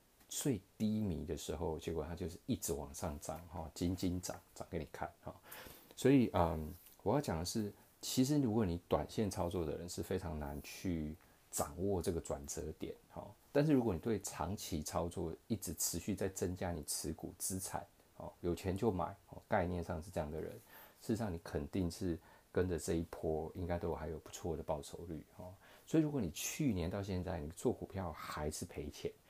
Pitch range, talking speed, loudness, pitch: 85-105 Hz, 275 characters per minute, -40 LUFS, 90 Hz